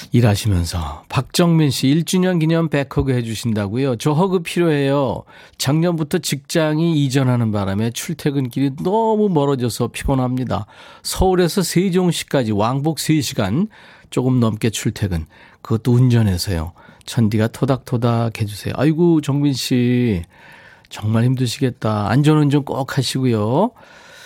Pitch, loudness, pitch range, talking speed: 135 Hz, -18 LUFS, 115-160 Hz, 295 characters per minute